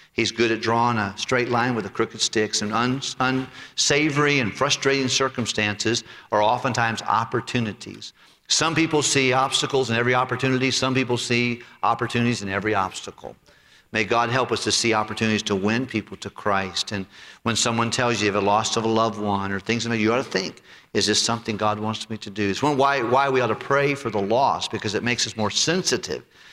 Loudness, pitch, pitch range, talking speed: -22 LUFS, 115 Hz, 110-130 Hz, 195 wpm